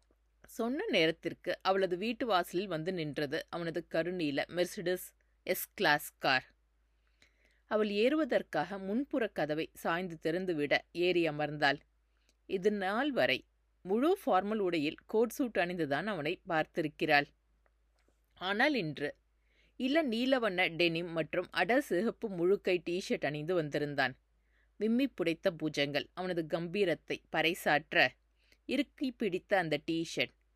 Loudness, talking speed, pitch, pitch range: -33 LUFS, 100 wpm, 175 Hz, 150-210 Hz